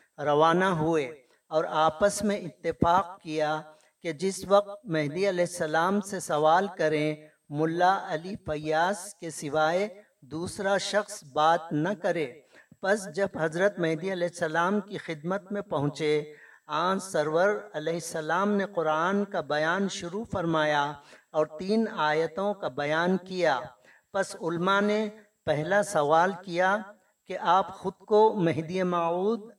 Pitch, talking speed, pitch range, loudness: 175 Hz, 130 wpm, 155-200 Hz, -27 LUFS